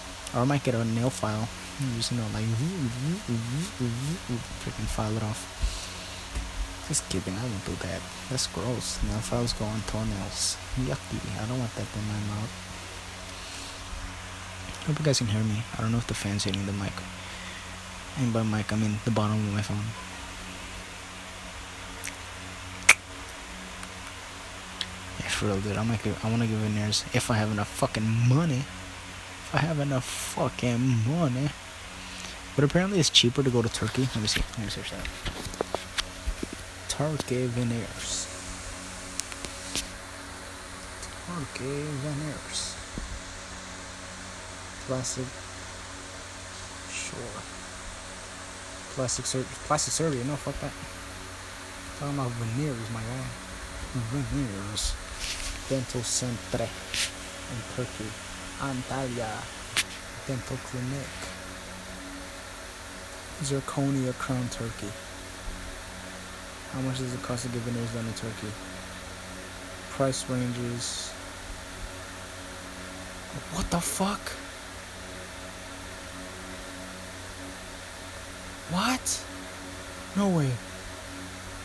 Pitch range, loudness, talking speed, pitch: 95-120 Hz, -31 LUFS, 115 wpm, 95 Hz